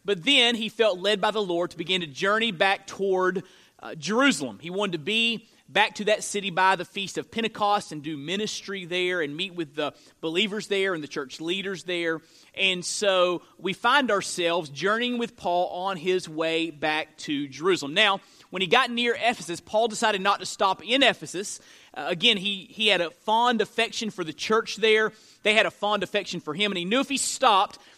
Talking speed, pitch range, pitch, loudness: 205 wpm, 180-220 Hz, 195 Hz, -25 LUFS